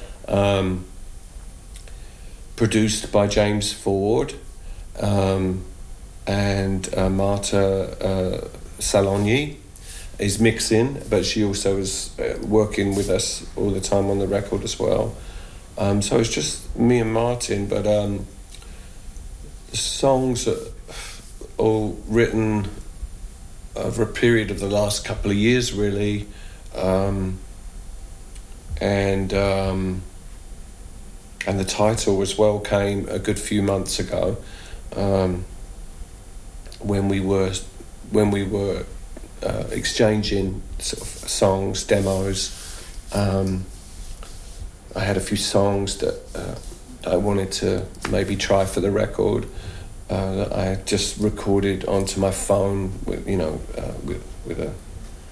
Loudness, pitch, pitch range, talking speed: -22 LUFS, 95 Hz, 95-105 Hz, 120 wpm